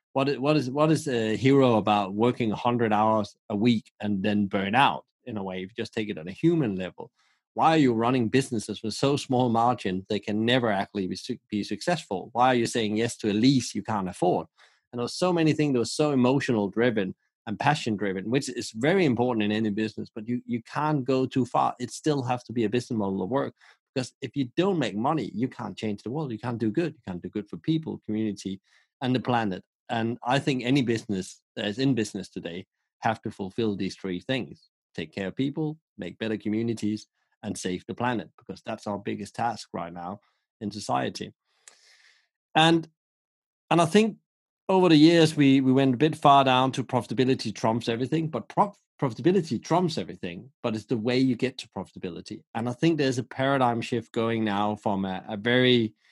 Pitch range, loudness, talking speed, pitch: 105-135 Hz, -26 LUFS, 210 wpm, 120 Hz